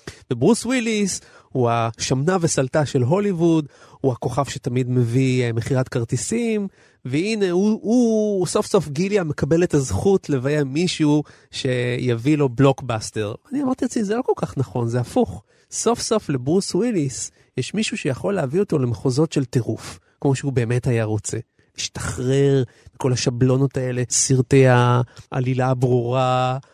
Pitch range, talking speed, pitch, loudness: 125-180 Hz, 140 wpm, 135 Hz, -21 LUFS